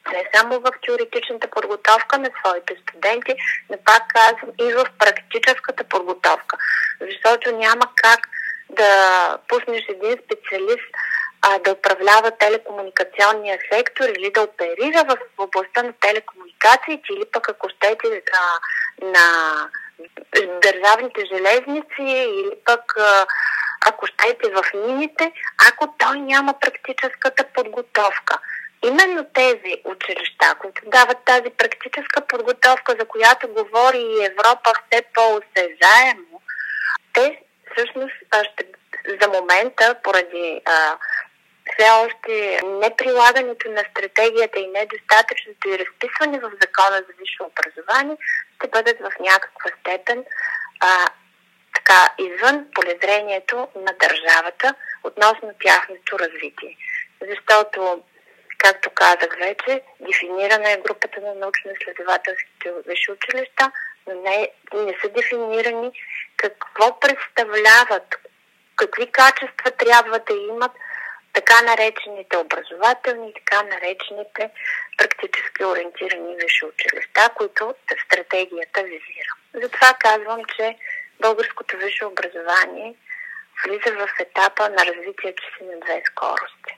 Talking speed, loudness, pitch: 105 wpm, -17 LUFS, 235 Hz